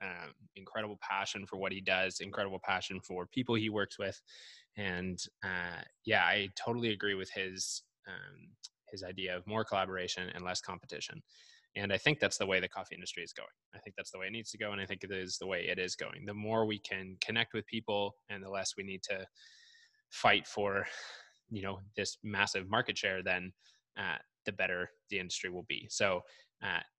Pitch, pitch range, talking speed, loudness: 95 Hz, 90-110 Hz, 205 wpm, -36 LUFS